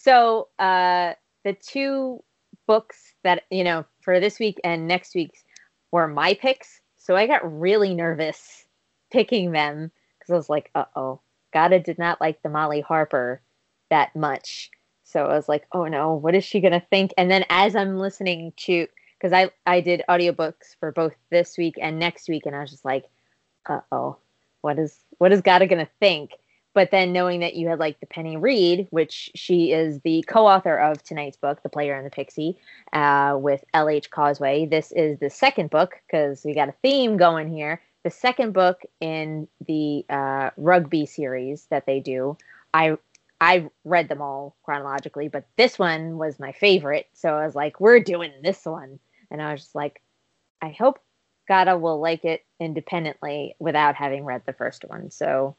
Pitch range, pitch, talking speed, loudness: 150-185 Hz, 165 Hz, 185 wpm, -22 LUFS